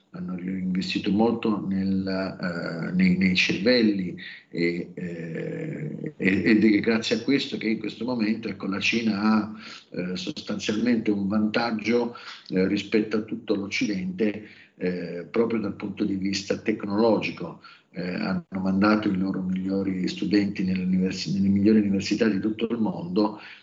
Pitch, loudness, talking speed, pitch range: 105 Hz, -25 LUFS, 135 wpm, 95-110 Hz